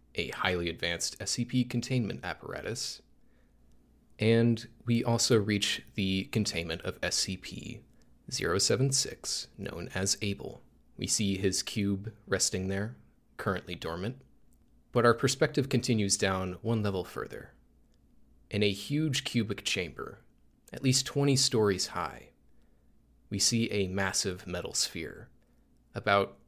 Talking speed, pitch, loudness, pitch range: 115 wpm, 105 Hz, -30 LUFS, 95-120 Hz